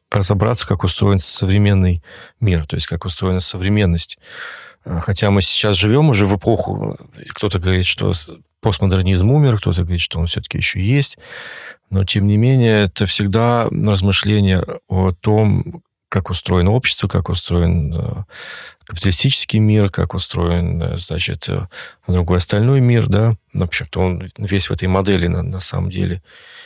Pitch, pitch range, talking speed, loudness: 95 Hz, 90-105 Hz, 140 wpm, -16 LUFS